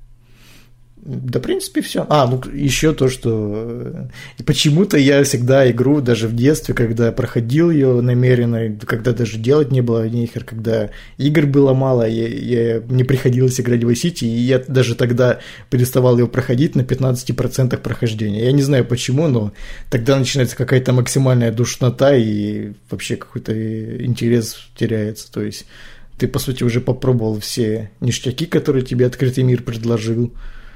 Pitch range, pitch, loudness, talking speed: 115-135 Hz, 125 Hz, -17 LUFS, 150 wpm